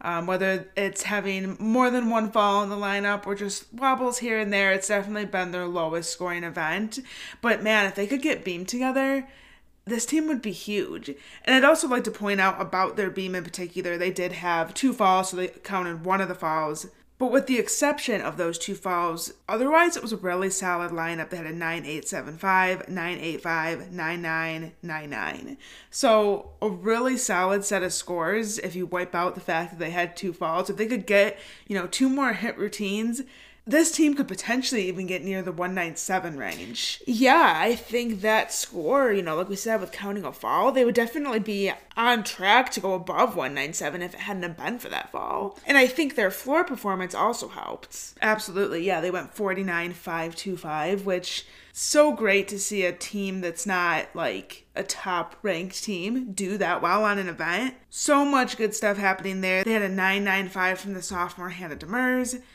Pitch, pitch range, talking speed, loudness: 195 Hz, 180-230 Hz, 200 wpm, -25 LUFS